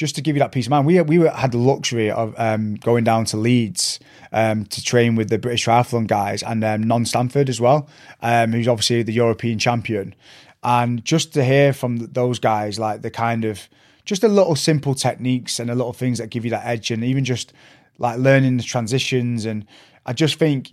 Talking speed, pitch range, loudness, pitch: 220 wpm, 115-135 Hz, -19 LUFS, 120 Hz